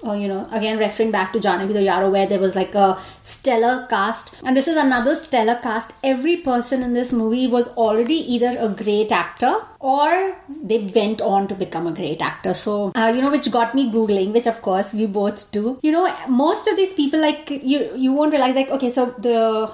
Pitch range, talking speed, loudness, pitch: 210-270 Hz, 220 wpm, -19 LUFS, 235 Hz